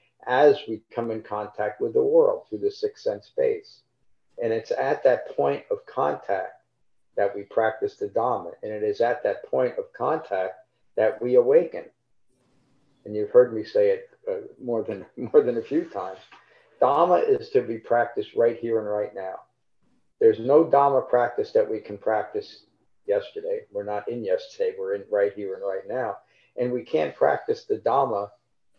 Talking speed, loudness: 180 wpm, -25 LUFS